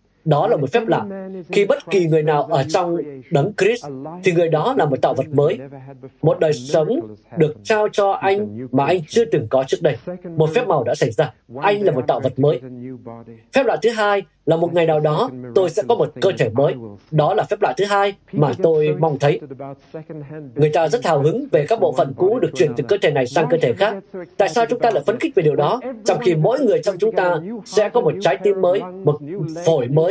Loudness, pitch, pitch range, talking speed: -18 LUFS, 165 Hz, 145-200 Hz, 240 wpm